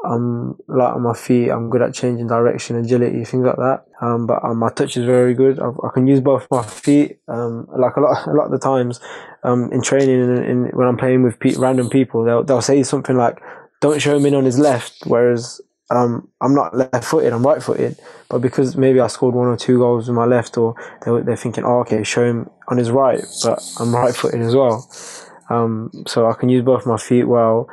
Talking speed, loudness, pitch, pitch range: 230 wpm, -17 LUFS, 125 Hz, 120-130 Hz